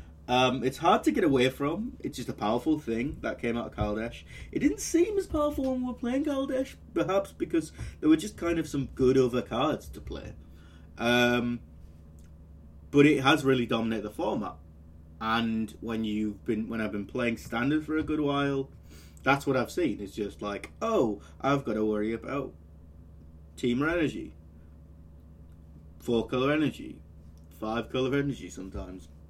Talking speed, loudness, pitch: 170 wpm, -29 LUFS, 115 Hz